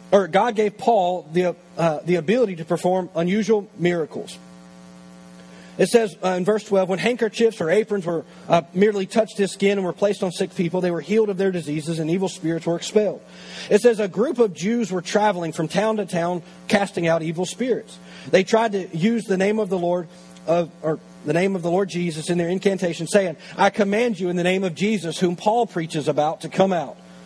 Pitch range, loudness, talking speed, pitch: 165-205 Hz, -21 LUFS, 215 wpm, 185 Hz